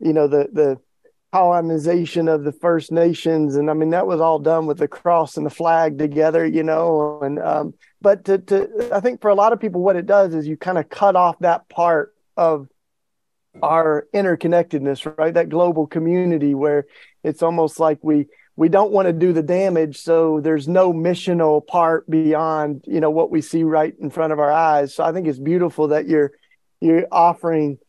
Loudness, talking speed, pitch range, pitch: -18 LUFS, 200 wpm, 155-175 Hz, 165 Hz